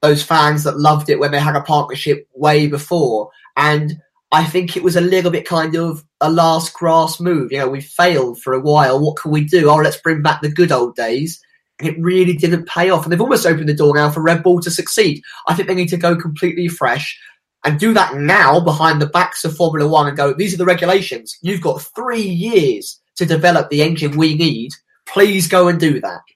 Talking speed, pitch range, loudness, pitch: 230 wpm, 150-180 Hz, -15 LUFS, 160 Hz